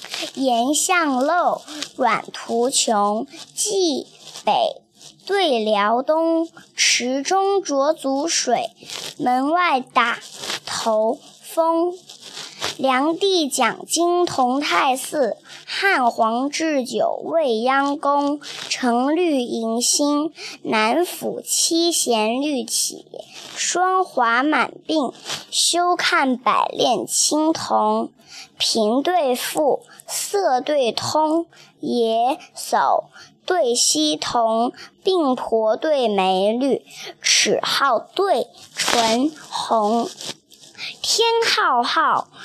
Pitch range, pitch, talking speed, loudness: 235-340 Hz, 285 Hz, 110 characters per minute, -19 LUFS